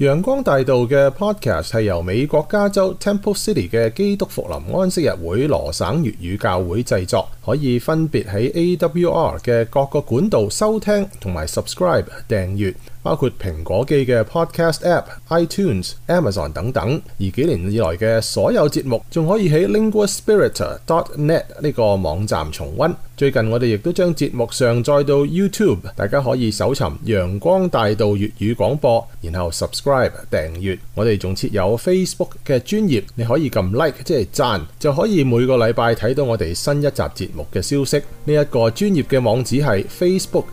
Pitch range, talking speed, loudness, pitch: 110-165 Hz, 375 characters per minute, -18 LUFS, 130 Hz